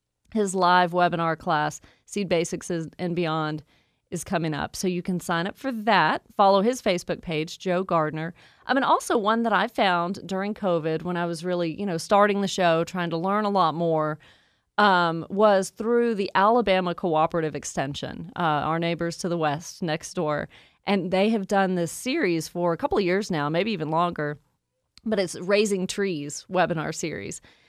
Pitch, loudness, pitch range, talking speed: 175 Hz, -24 LUFS, 165-200 Hz, 185 wpm